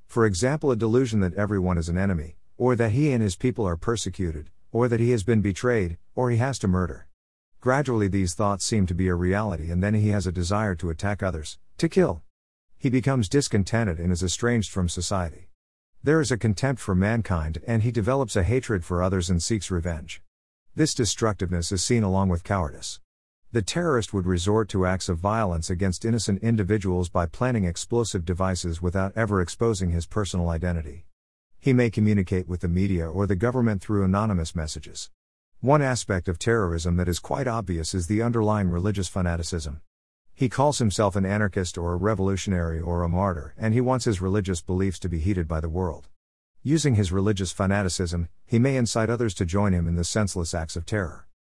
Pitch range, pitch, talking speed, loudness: 85-115 Hz, 95 Hz, 190 wpm, -25 LUFS